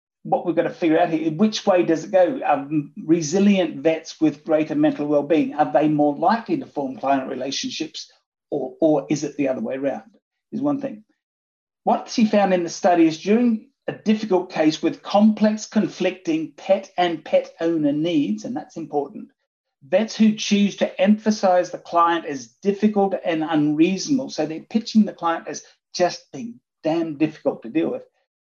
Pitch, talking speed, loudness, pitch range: 185 Hz, 175 wpm, -21 LUFS, 160-220 Hz